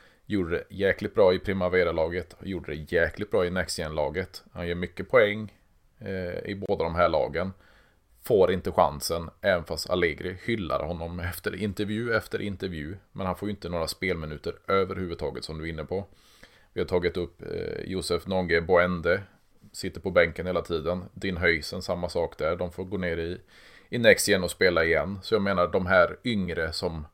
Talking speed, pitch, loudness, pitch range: 180 wpm, 90 Hz, -27 LUFS, 85-95 Hz